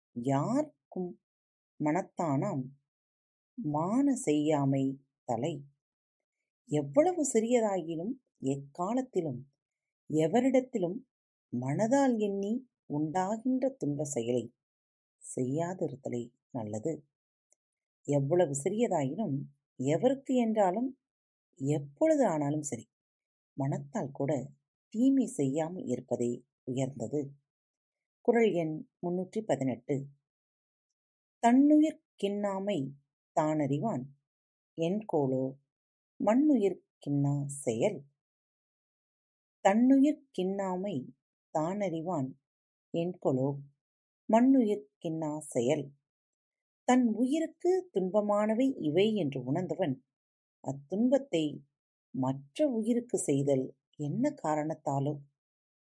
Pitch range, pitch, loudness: 135-215 Hz, 155 Hz, -31 LUFS